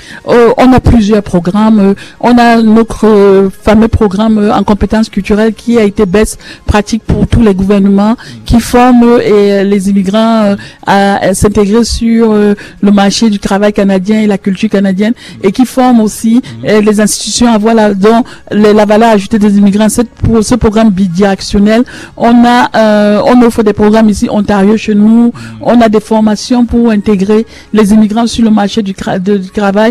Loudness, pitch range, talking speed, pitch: -7 LUFS, 205-230 Hz, 185 wpm, 215 Hz